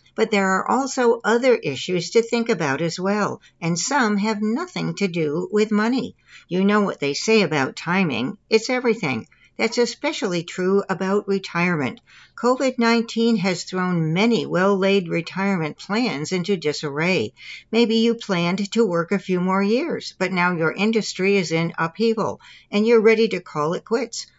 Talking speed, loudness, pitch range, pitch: 160 wpm, -21 LUFS, 180-230 Hz, 200 Hz